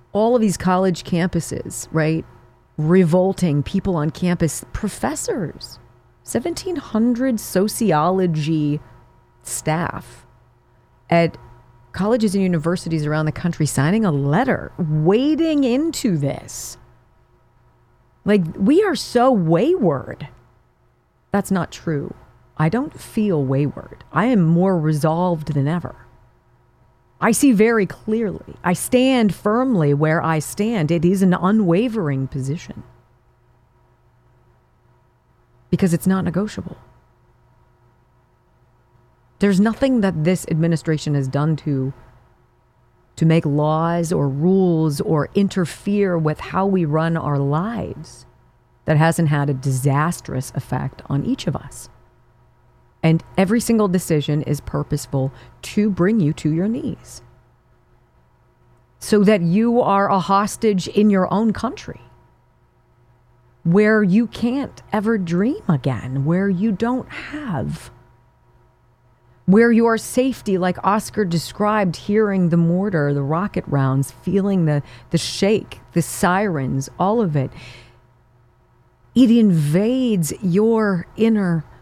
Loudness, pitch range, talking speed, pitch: -19 LUFS, 150-210 Hz, 110 wpm, 175 Hz